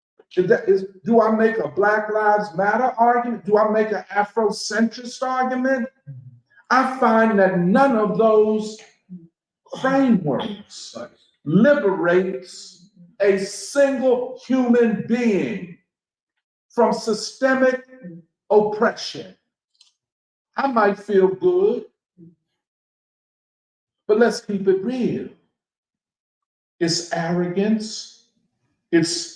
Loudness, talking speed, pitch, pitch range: -20 LUFS, 90 wpm, 215 Hz, 185-240 Hz